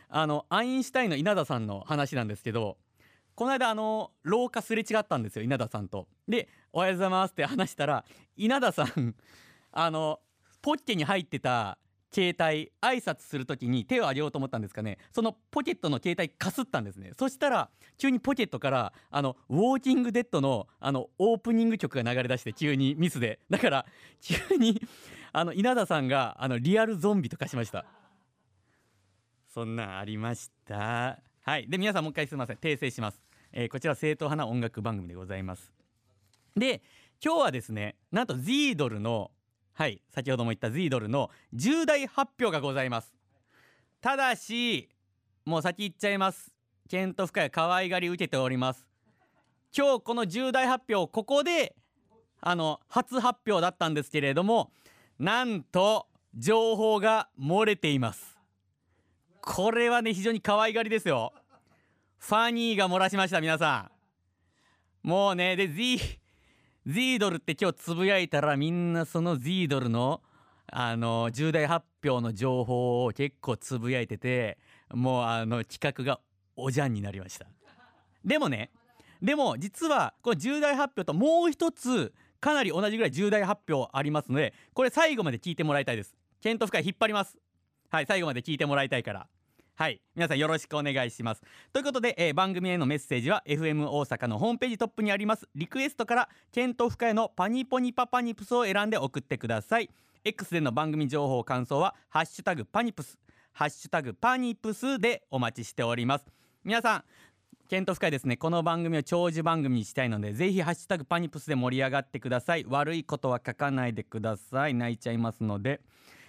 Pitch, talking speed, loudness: 155 Hz, 365 characters per minute, -29 LUFS